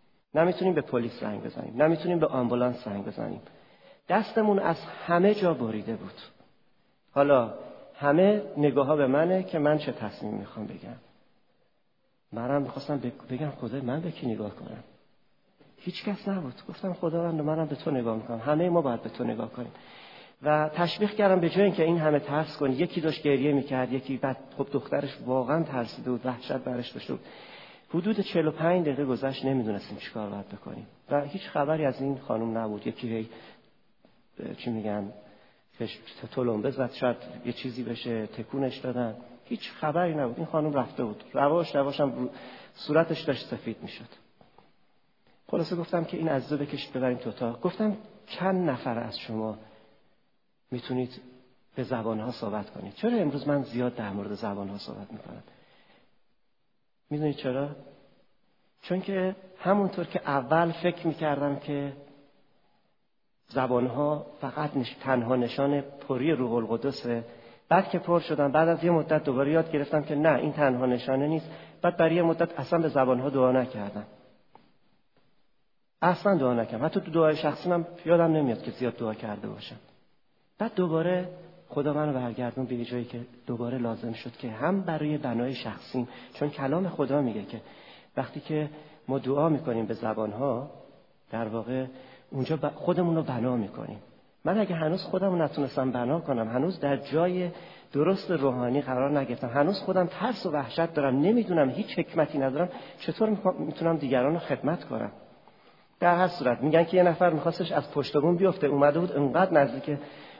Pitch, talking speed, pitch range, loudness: 145 Hz, 160 wpm, 125-170 Hz, -28 LUFS